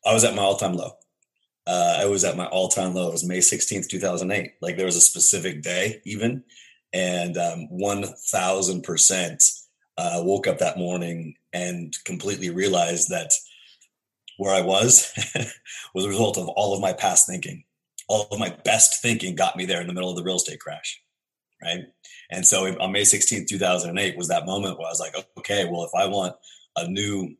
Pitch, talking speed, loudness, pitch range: 95 Hz, 195 wpm, -21 LUFS, 90-100 Hz